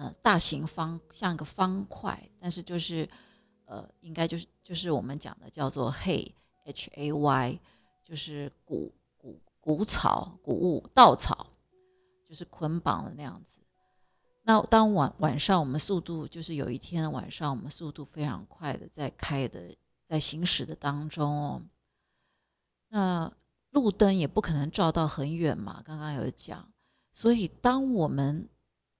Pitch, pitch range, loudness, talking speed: 160 Hz, 145-185 Hz, -29 LUFS, 215 characters per minute